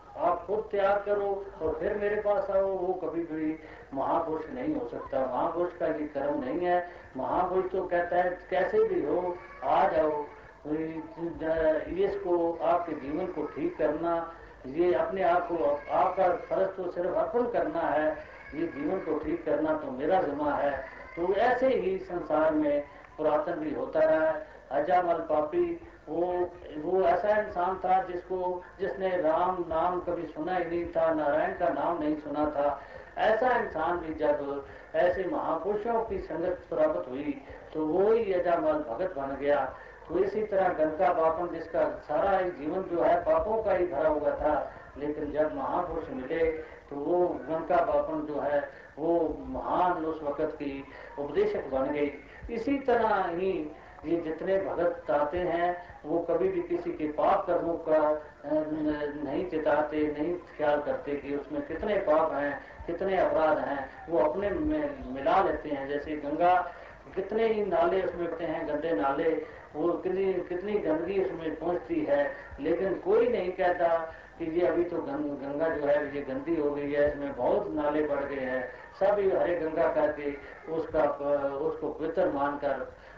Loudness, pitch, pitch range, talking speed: -29 LUFS, 170 Hz, 150-185 Hz, 160 wpm